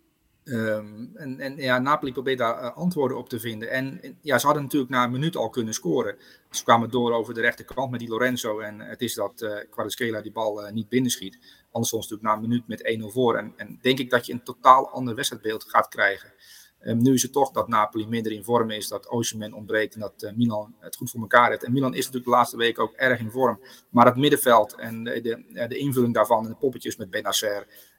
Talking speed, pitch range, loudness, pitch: 240 wpm, 110-130 Hz, -24 LUFS, 120 Hz